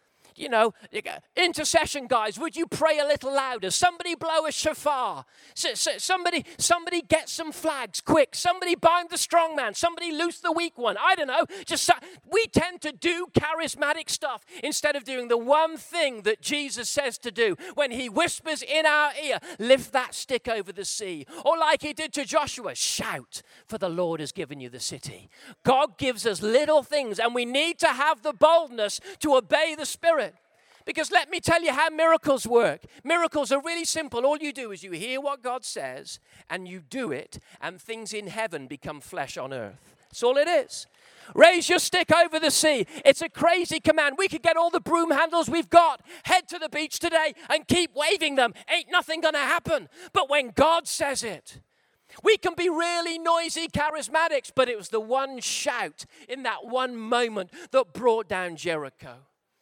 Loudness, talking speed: -25 LUFS, 190 wpm